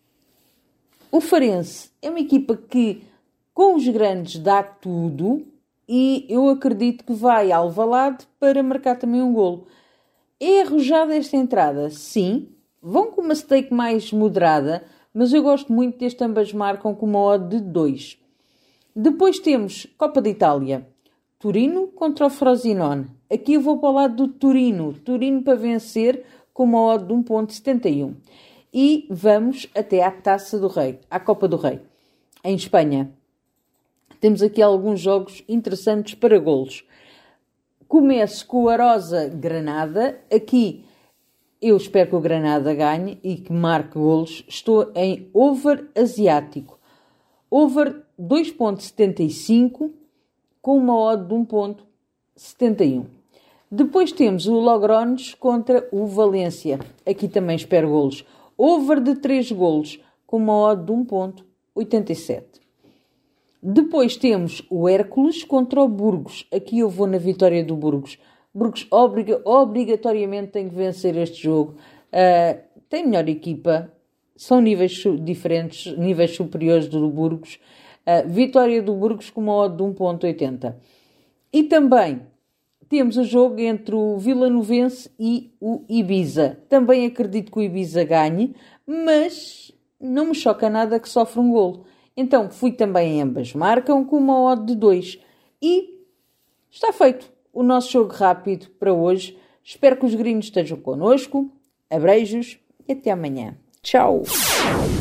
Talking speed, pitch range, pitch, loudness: 135 wpm, 180-255 Hz, 220 Hz, -19 LUFS